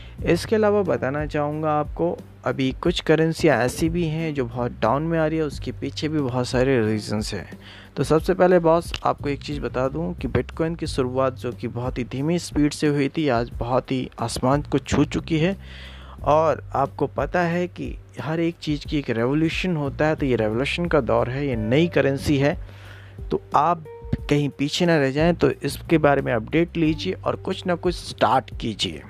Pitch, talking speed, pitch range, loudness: 140 Hz, 200 wpm, 120-160 Hz, -23 LUFS